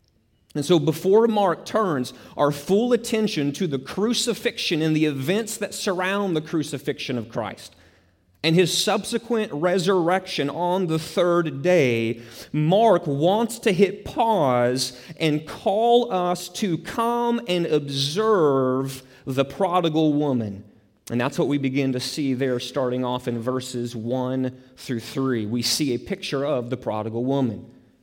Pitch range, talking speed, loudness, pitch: 125-190 Hz, 140 wpm, -23 LUFS, 150 Hz